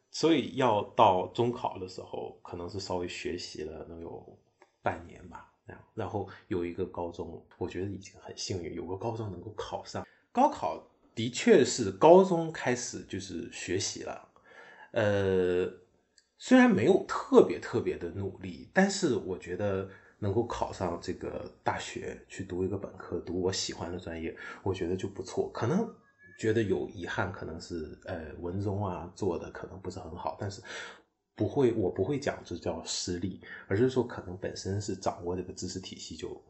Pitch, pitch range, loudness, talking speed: 95 Hz, 90-115 Hz, -31 LUFS, 255 characters per minute